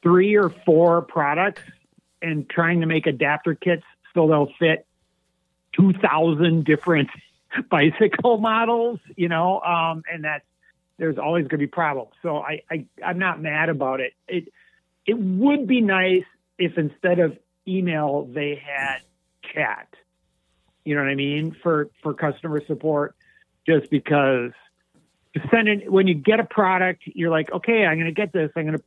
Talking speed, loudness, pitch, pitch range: 160 wpm, -21 LUFS, 165 Hz, 150-185 Hz